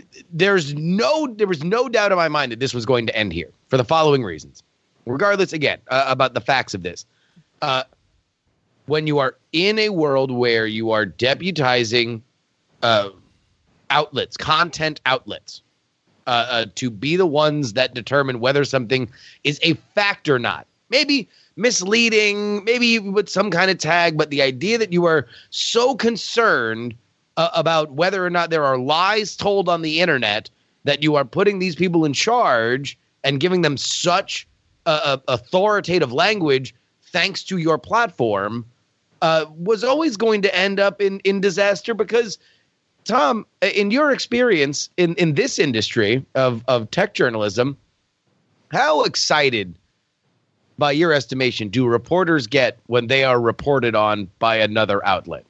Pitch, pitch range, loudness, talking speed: 150 Hz, 125-190 Hz, -19 LUFS, 155 wpm